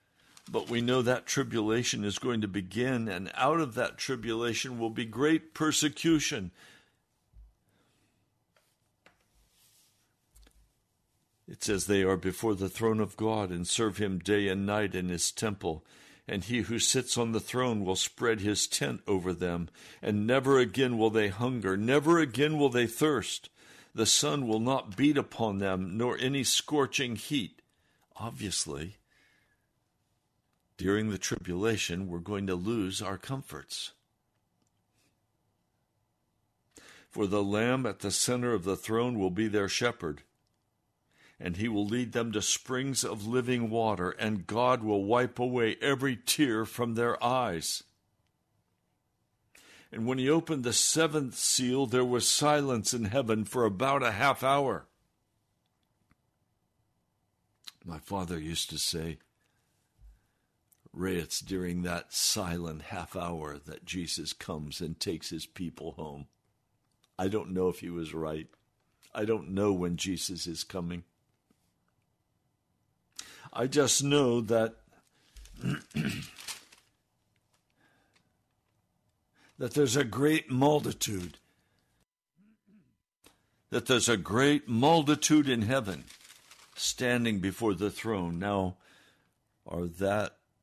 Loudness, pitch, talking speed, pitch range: -30 LUFS, 110 Hz, 125 wpm, 95-125 Hz